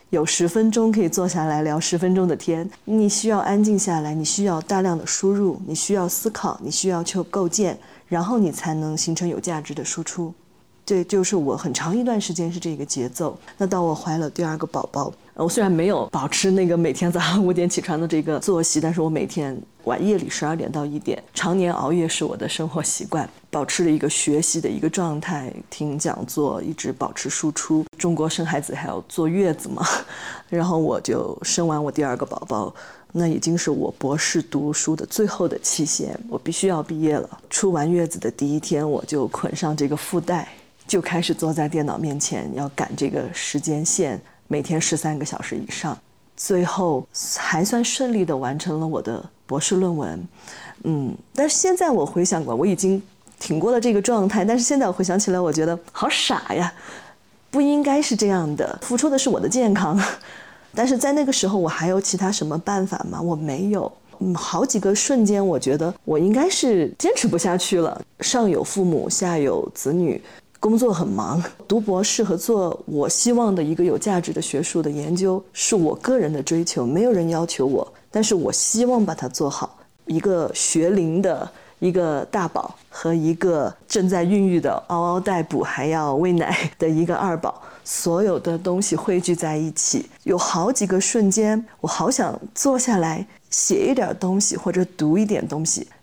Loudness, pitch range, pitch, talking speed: -21 LUFS, 160-195 Hz, 175 Hz, 285 characters per minute